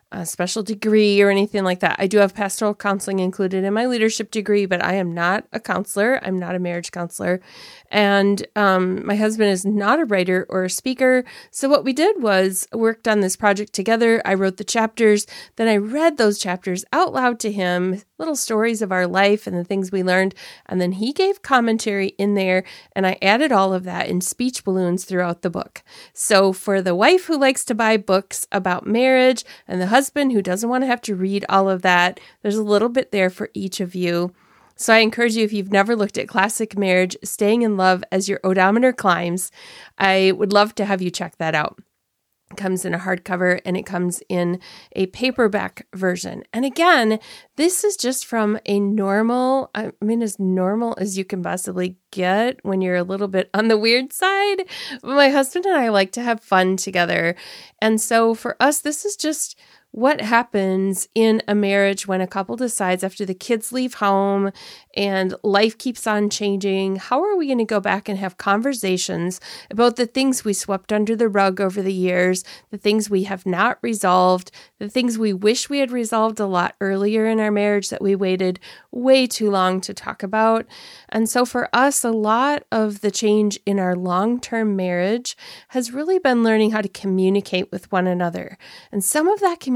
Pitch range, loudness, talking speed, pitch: 190-230 Hz, -19 LUFS, 205 wpm, 205 Hz